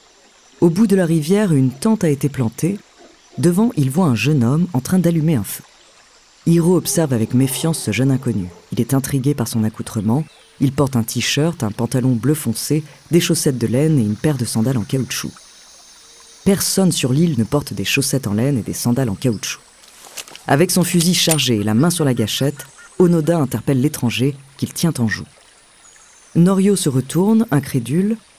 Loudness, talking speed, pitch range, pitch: -17 LUFS, 185 wpm, 120-170 Hz, 140 Hz